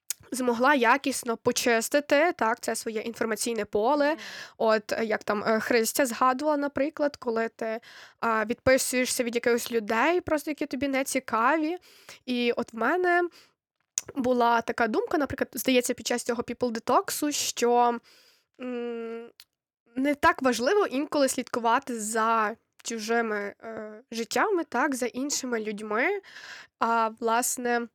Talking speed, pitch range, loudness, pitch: 115 wpm, 230-290 Hz, -26 LUFS, 245 Hz